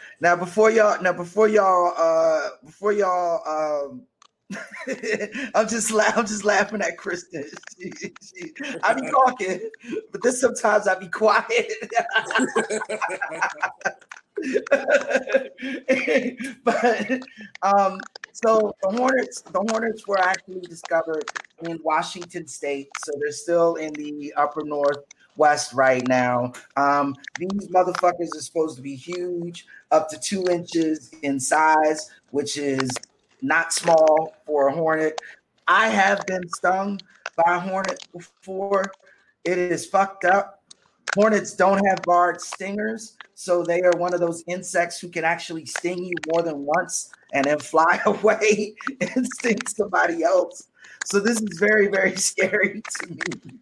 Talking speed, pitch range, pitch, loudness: 130 wpm, 160-210 Hz, 180 Hz, -22 LUFS